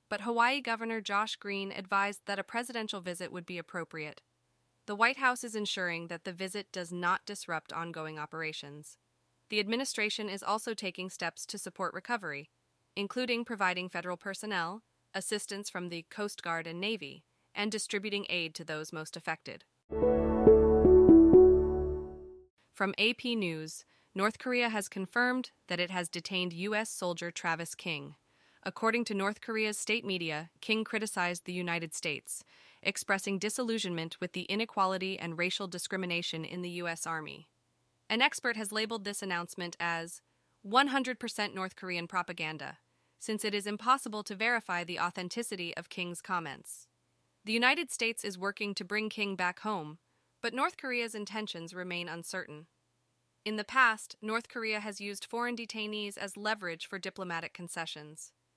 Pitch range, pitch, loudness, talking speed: 175-220 Hz, 195 Hz, -32 LUFS, 145 wpm